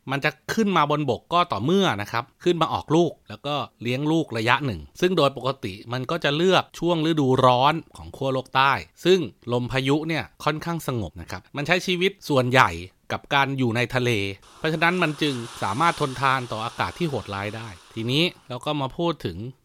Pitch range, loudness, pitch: 120-160 Hz, -23 LUFS, 135 Hz